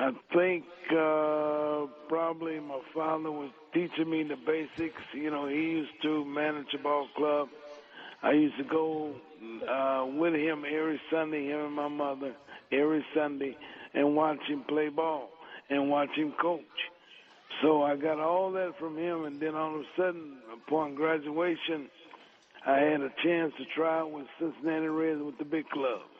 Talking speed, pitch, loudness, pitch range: 165 wpm, 155 Hz, -31 LUFS, 145-160 Hz